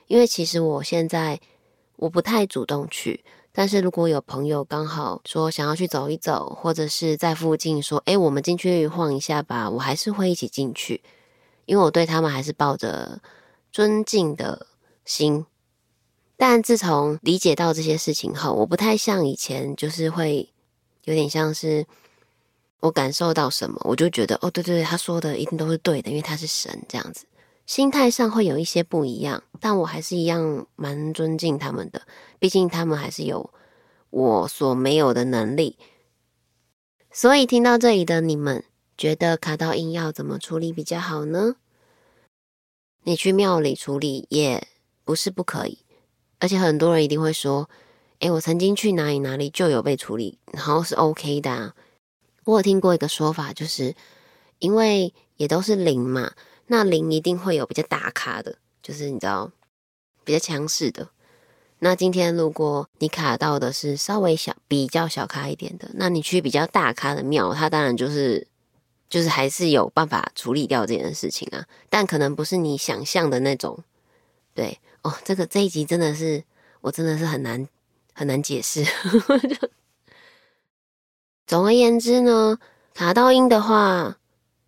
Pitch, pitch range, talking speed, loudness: 160 Hz, 145-185 Hz, 250 characters per minute, -22 LUFS